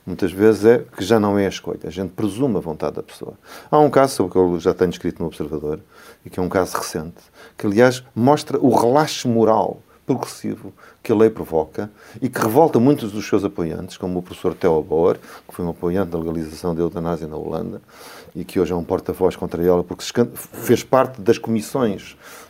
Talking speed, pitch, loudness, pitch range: 215 wpm, 95 Hz, -20 LUFS, 90-115 Hz